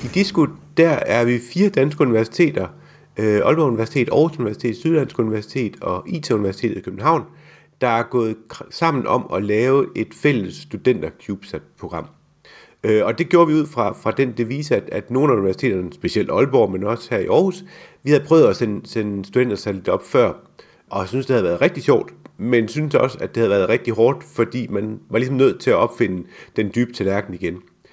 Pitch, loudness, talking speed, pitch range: 120 Hz, -19 LUFS, 195 wpm, 110-150 Hz